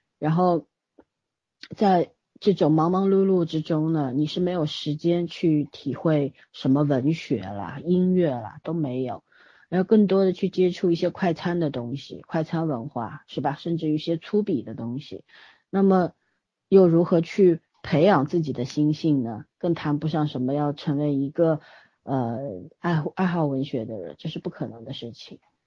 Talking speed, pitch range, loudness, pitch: 245 characters per minute, 140-175 Hz, -24 LUFS, 160 Hz